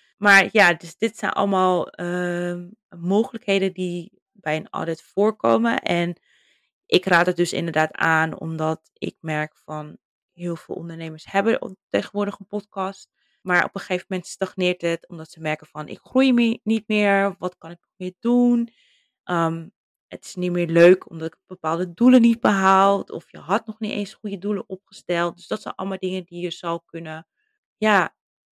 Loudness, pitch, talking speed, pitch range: -22 LUFS, 185 Hz, 175 wpm, 170-205 Hz